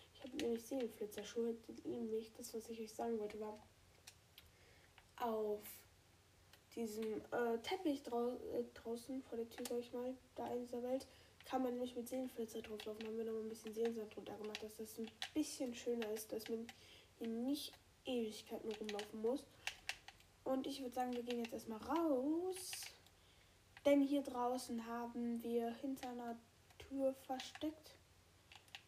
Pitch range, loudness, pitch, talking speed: 220-255 Hz, -45 LUFS, 235 Hz, 160 wpm